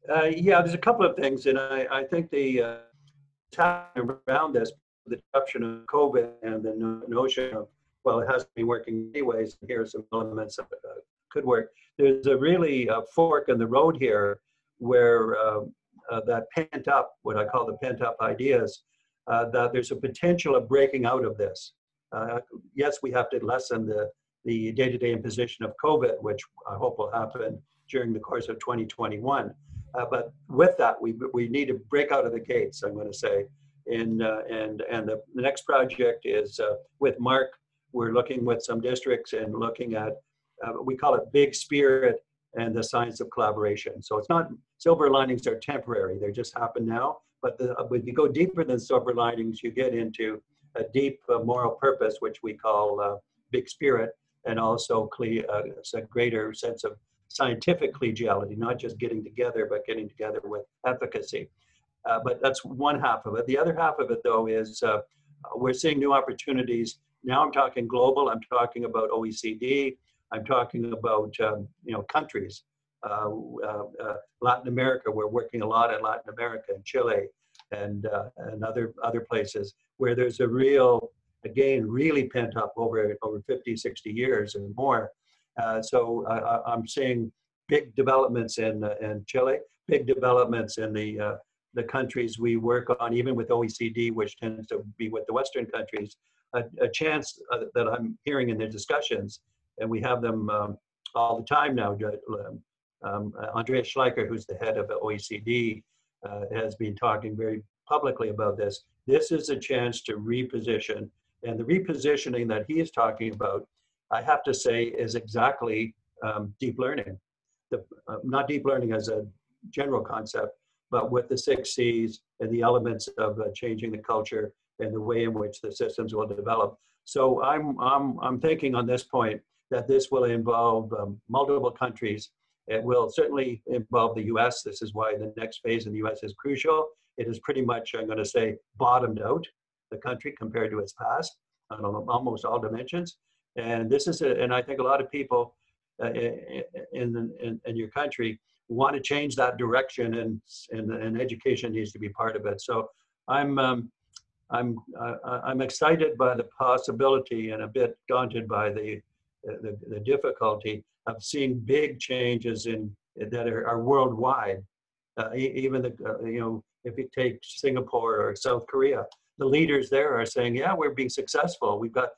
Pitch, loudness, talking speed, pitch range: 125 Hz, -27 LUFS, 180 wpm, 115-145 Hz